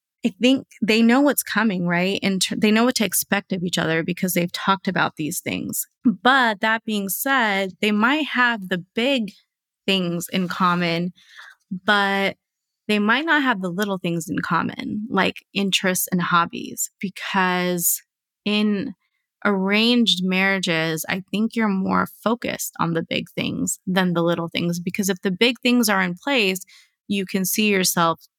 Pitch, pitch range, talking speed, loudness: 195 Hz, 180-220 Hz, 165 wpm, -21 LUFS